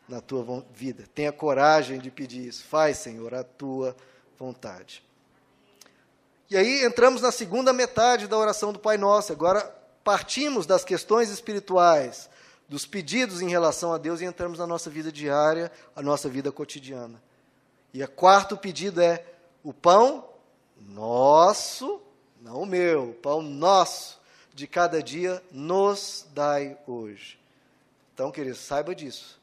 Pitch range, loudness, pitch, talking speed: 130-190 Hz, -24 LUFS, 155 Hz, 140 wpm